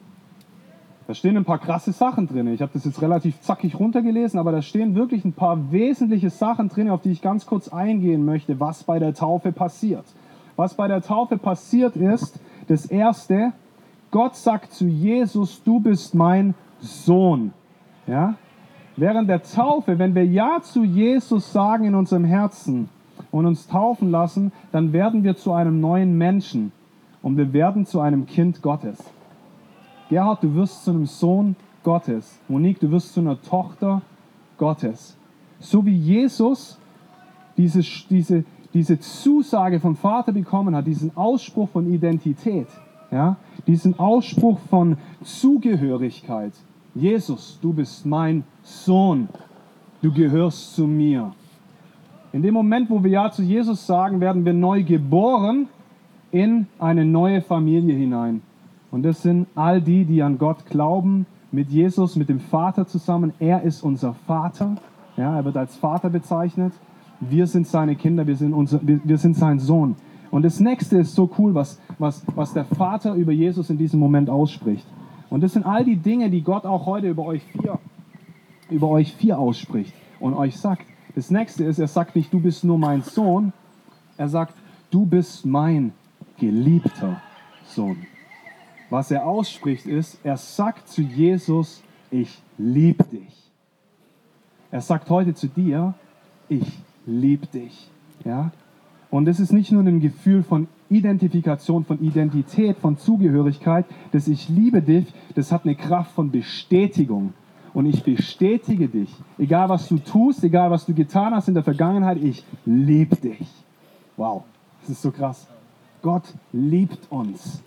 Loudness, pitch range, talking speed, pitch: -20 LUFS, 155-195 Hz, 155 wpm, 175 Hz